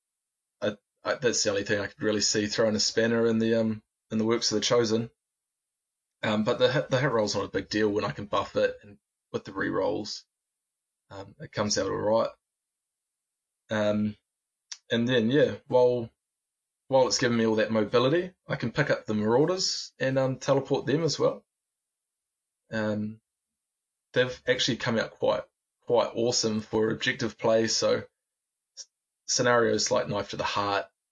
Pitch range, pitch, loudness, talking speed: 110-130 Hz, 115 Hz, -27 LUFS, 175 wpm